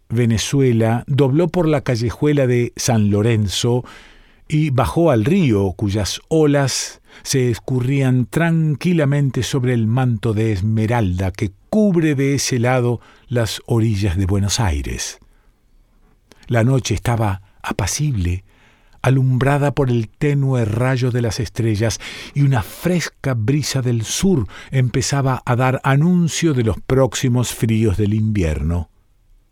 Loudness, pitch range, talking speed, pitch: -18 LUFS, 110-140 Hz, 120 wpm, 125 Hz